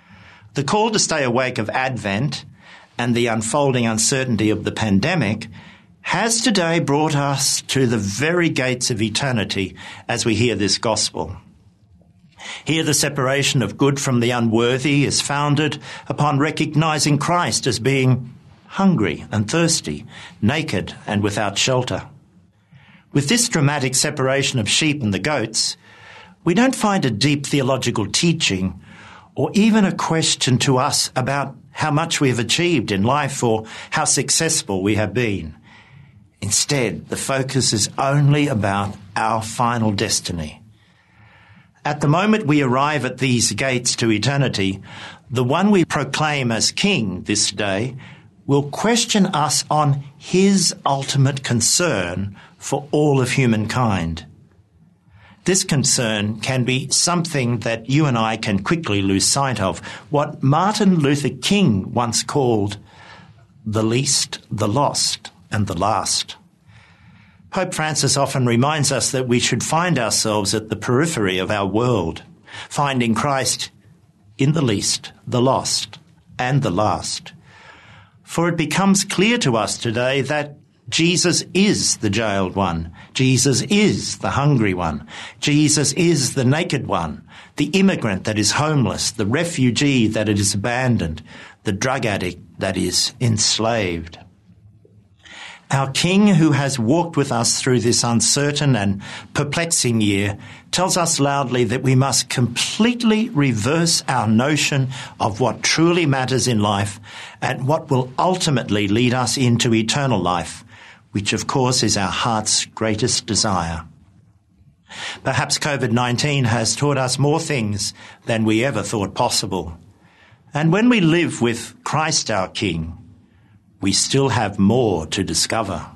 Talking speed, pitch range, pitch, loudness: 140 wpm, 105-145 Hz, 125 Hz, -18 LUFS